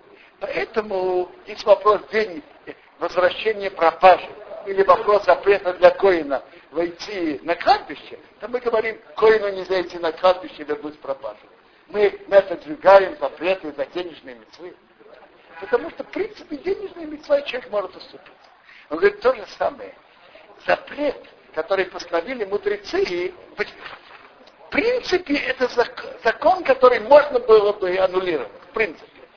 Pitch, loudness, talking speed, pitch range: 210 Hz, -20 LUFS, 130 wpm, 180-295 Hz